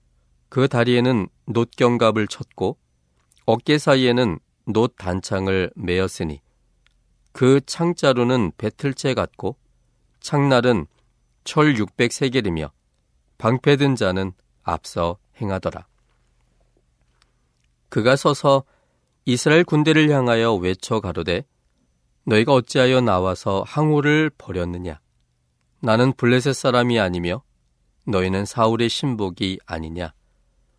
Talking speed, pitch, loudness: 220 characters per minute, 100 Hz, -20 LUFS